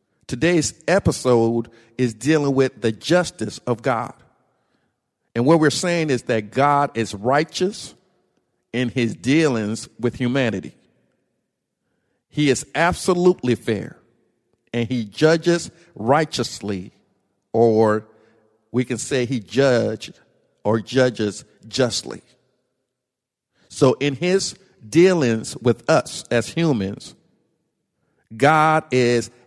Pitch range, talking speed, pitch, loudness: 115-150 Hz, 100 wpm, 125 Hz, -20 LUFS